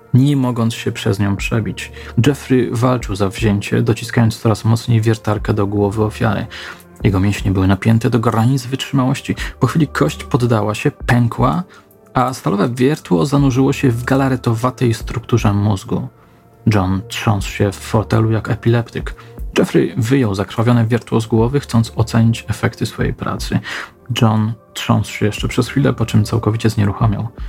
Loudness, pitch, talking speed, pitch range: -16 LUFS, 115 Hz, 145 wpm, 105-125 Hz